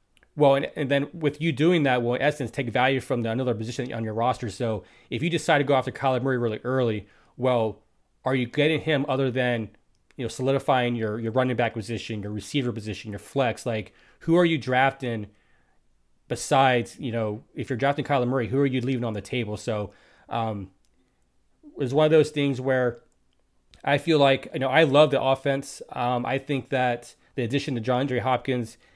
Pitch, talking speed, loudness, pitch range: 130 Hz, 205 wpm, -25 LUFS, 115-140 Hz